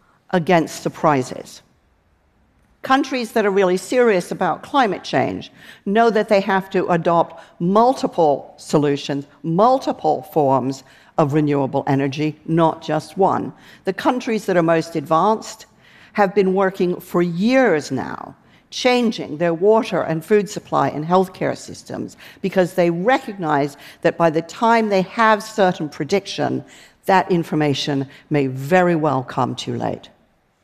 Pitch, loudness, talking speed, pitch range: 175 Hz, -19 LUFS, 130 wpm, 150-205 Hz